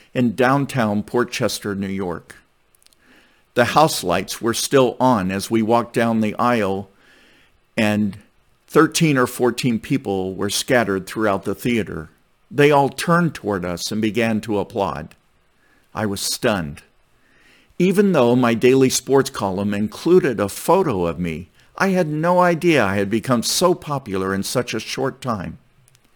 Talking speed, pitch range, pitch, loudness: 145 wpm, 100-135 Hz, 115 Hz, -19 LUFS